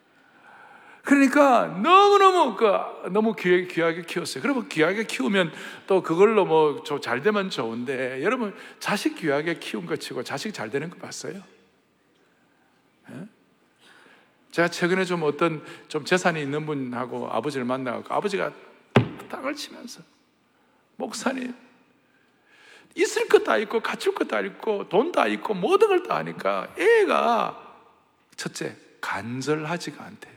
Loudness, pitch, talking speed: -23 LUFS, 200 Hz, 265 characters per minute